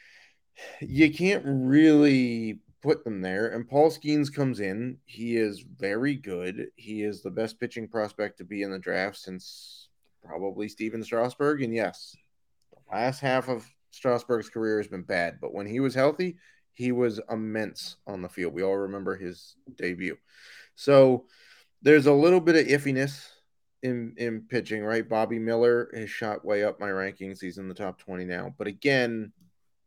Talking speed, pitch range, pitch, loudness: 170 wpm, 100-135 Hz, 115 Hz, -26 LUFS